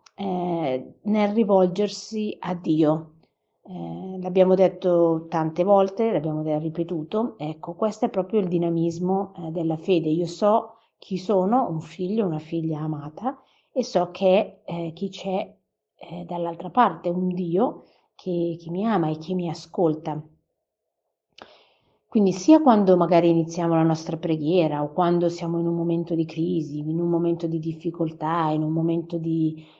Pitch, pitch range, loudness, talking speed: 170 Hz, 165-190 Hz, -24 LUFS, 145 wpm